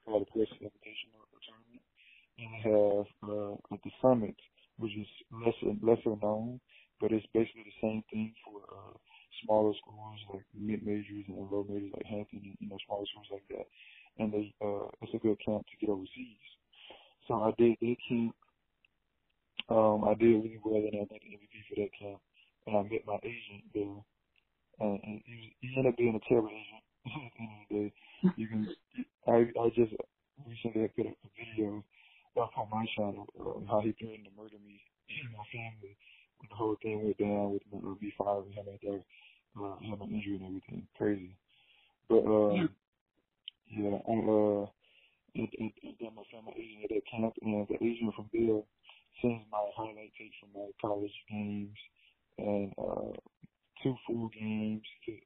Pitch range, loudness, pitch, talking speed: 105-115 Hz, -35 LUFS, 105 Hz, 180 wpm